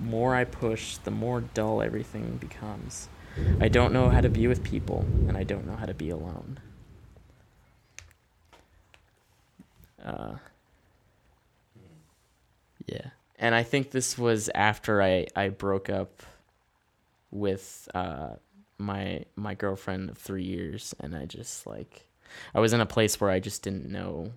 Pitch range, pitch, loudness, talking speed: 95-115 Hz, 100 Hz, -29 LUFS, 145 wpm